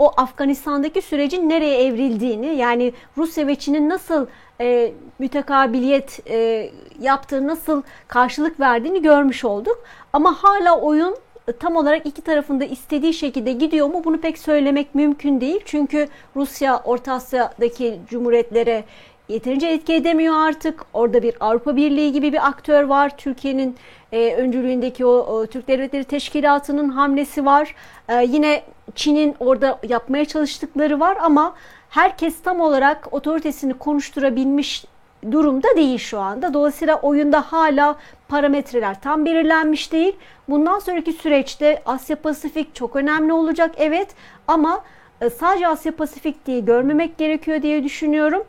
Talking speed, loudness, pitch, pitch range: 125 wpm, -19 LUFS, 290 Hz, 260-315 Hz